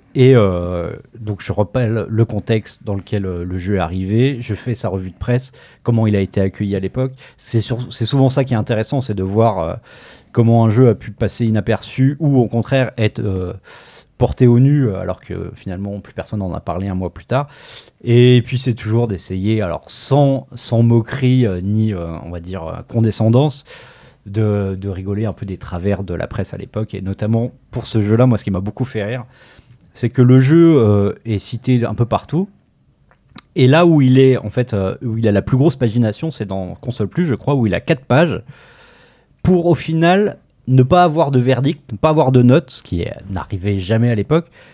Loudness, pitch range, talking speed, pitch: -16 LUFS, 100-130 Hz, 210 wpm, 115 Hz